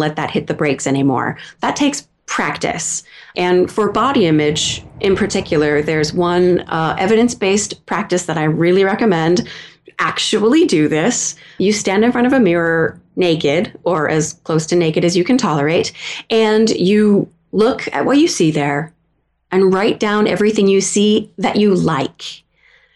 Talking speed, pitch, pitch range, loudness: 160 wpm, 185 Hz, 160-215 Hz, -15 LUFS